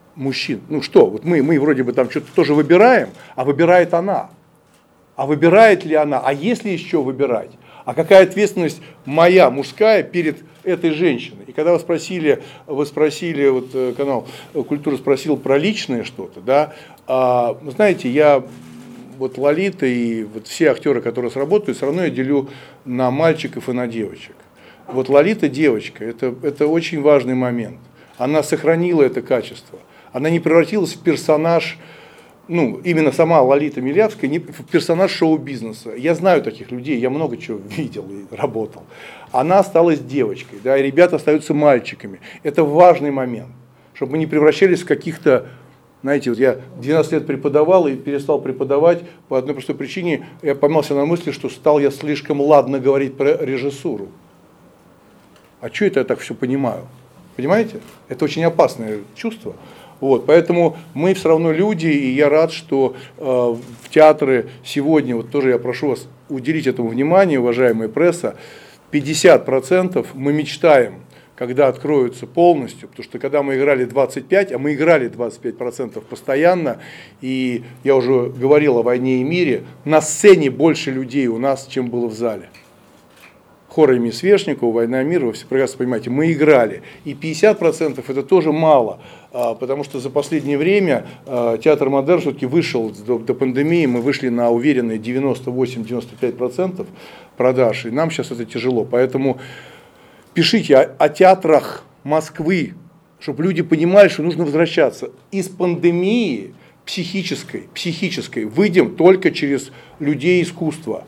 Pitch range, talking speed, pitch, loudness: 130-165 Hz, 145 wpm, 145 Hz, -17 LUFS